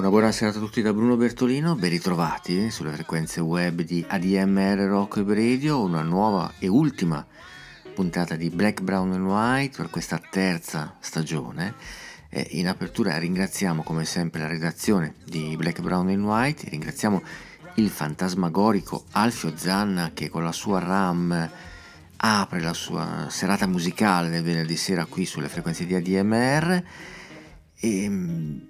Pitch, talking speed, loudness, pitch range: 90 Hz, 140 wpm, -25 LUFS, 85-105 Hz